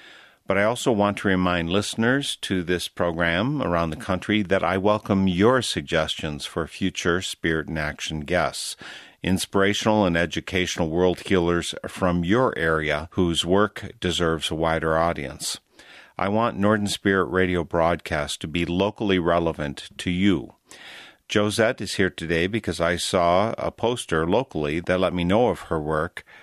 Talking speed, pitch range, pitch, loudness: 150 wpm, 85-100 Hz, 90 Hz, -23 LUFS